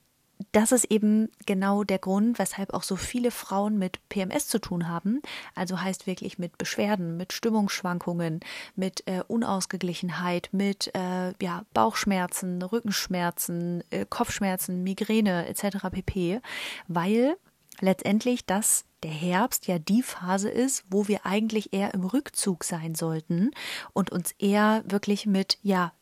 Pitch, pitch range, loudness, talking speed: 195 Hz, 180-215 Hz, -27 LUFS, 135 wpm